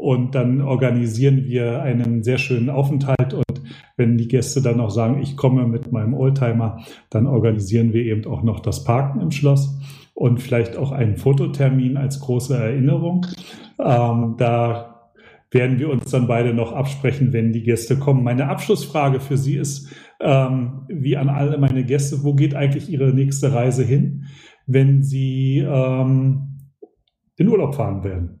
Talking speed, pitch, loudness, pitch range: 160 wpm, 130 Hz, -19 LUFS, 120-140 Hz